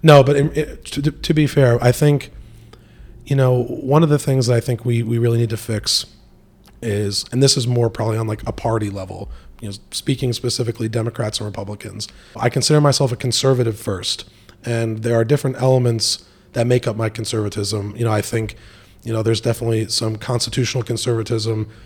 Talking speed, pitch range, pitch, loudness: 190 wpm, 110-125 Hz, 115 Hz, -19 LUFS